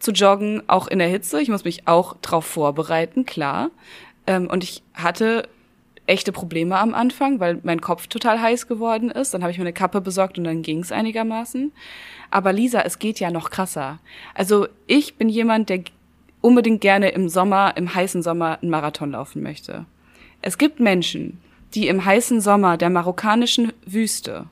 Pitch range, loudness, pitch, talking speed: 170-225 Hz, -20 LUFS, 190 Hz, 180 wpm